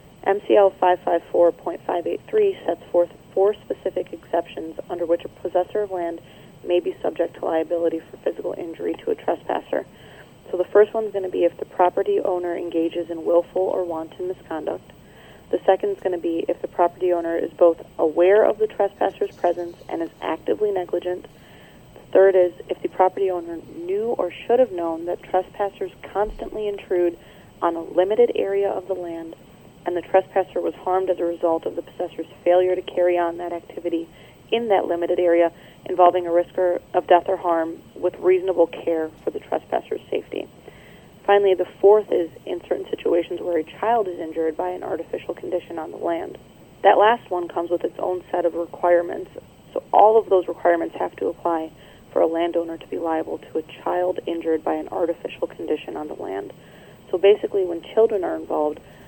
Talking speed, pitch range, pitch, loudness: 190 wpm, 170-195 Hz, 180 Hz, -22 LUFS